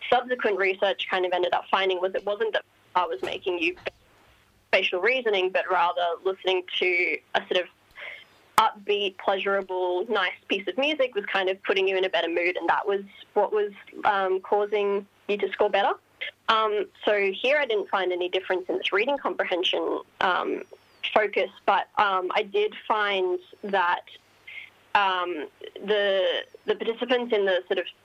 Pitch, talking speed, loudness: 205 Hz, 165 wpm, -25 LUFS